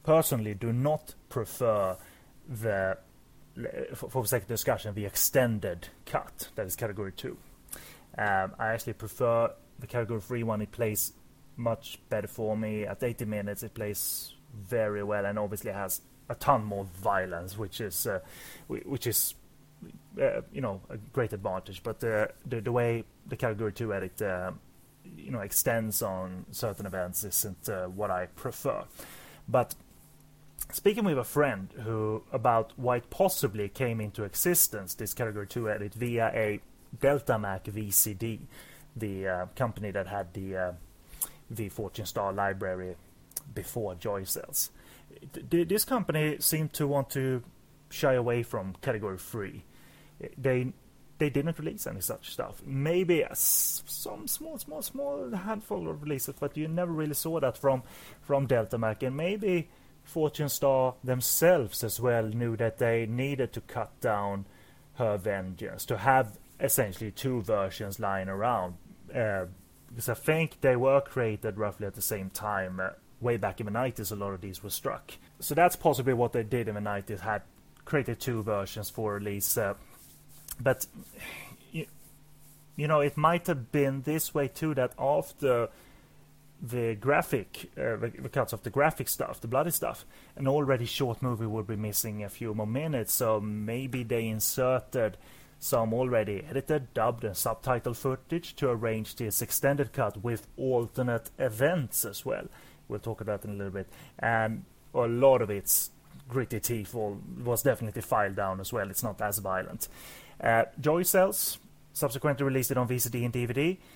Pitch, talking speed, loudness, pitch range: 115 Hz, 160 wpm, -30 LUFS, 105-140 Hz